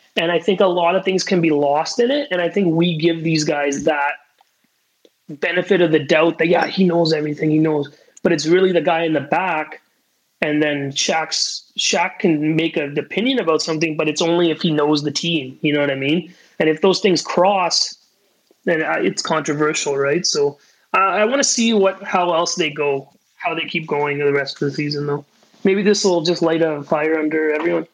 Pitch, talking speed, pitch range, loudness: 165 Hz, 215 wpm, 150-180 Hz, -18 LUFS